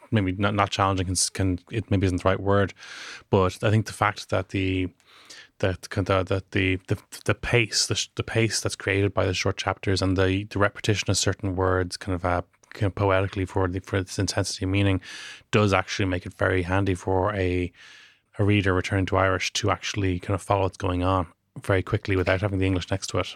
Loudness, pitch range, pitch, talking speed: -25 LUFS, 95-100 Hz, 95 Hz, 215 wpm